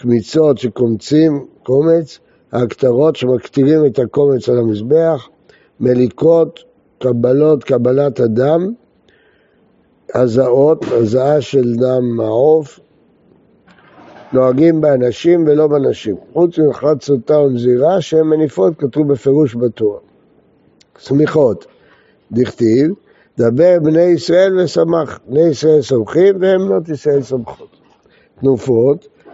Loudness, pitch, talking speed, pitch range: -13 LUFS, 145 Hz, 90 wpm, 125-160 Hz